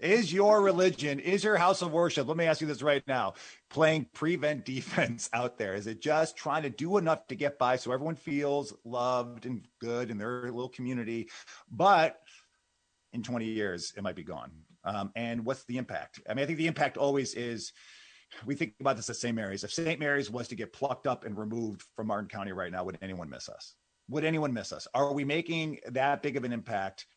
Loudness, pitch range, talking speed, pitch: -31 LUFS, 115-155 Hz, 220 wpm, 130 Hz